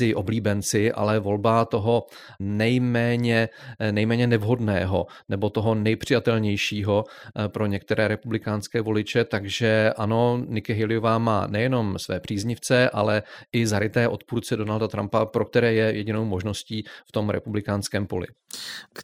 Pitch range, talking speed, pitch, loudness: 105-115 Hz, 115 wpm, 110 Hz, -24 LUFS